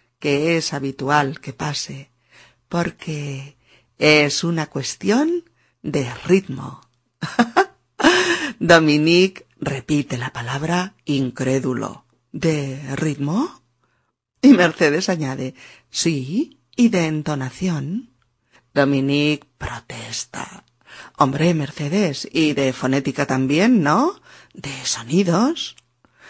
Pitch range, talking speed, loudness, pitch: 130-170 Hz, 80 wpm, -19 LUFS, 145 Hz